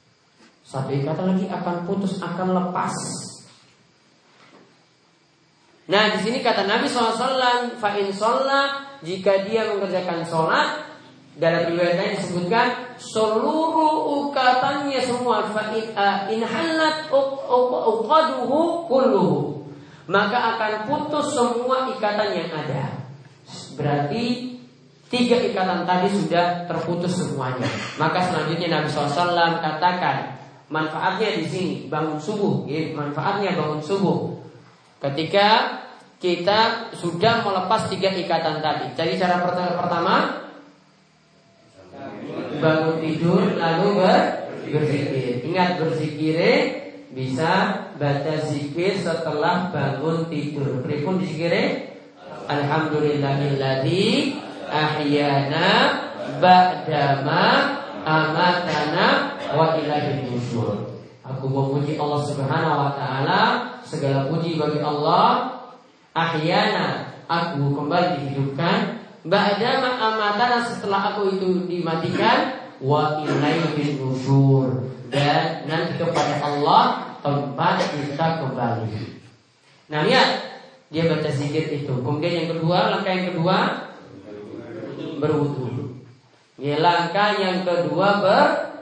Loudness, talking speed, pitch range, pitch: -21 LUFS, 90 wpm, 150-215 Hz, 175 Hz